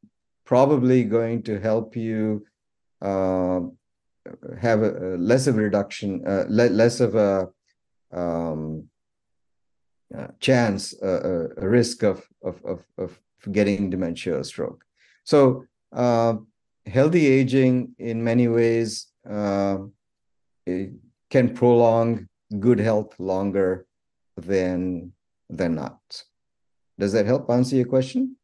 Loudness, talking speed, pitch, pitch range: -22 LUFS, 115 wpm, 110 Hz, 95-120 Hz